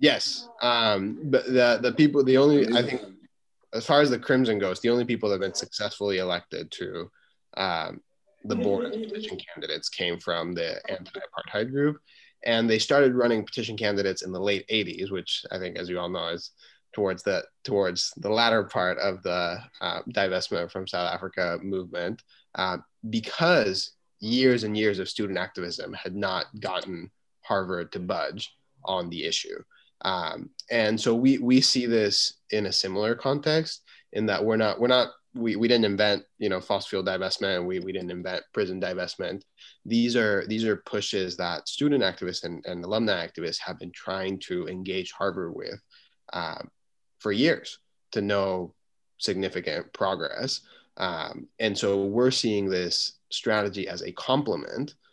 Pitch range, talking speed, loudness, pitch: 95-130 Hz, 170 wpm, -26 LUFS, 110 Hz